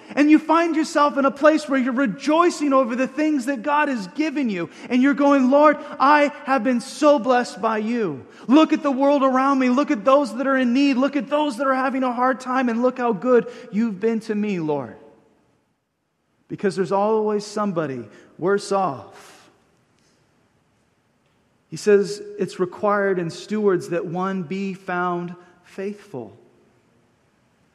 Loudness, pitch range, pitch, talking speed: -20 LUFS, 200-280 Hz, 250 Hz, 165 wpm